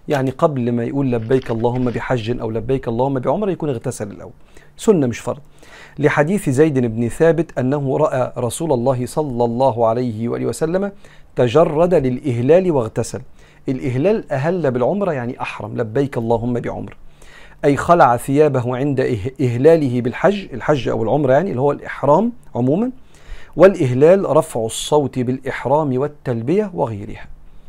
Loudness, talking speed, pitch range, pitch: -18 LUFS, 130 wpm, 120-150 Hz, 130 Hz